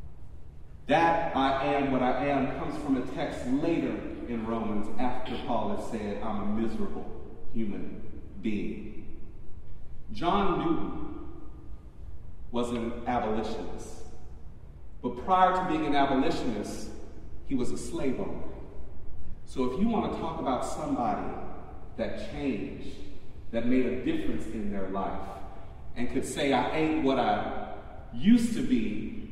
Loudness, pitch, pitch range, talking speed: -30 LUFS, 115 Hz, 100-135 Hz, 135 wpm